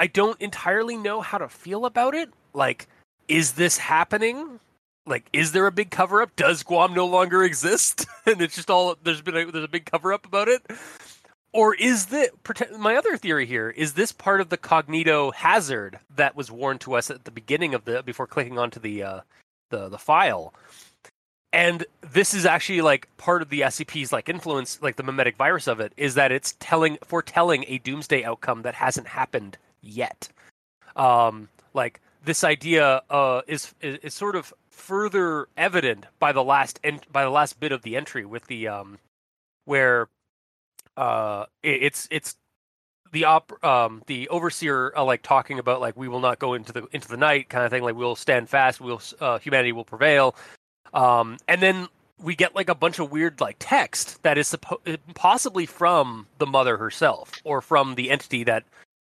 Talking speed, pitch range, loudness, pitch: 190 wpm, 130-180 Hz, -23 LUFS, 155 Hz